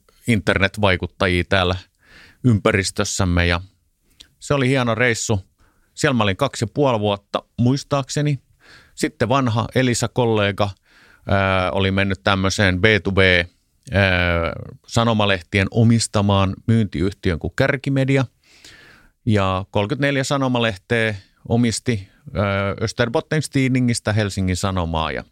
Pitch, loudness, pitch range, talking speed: 105 Hz, -19 LUFS, 95-120 Hz, 85 wpm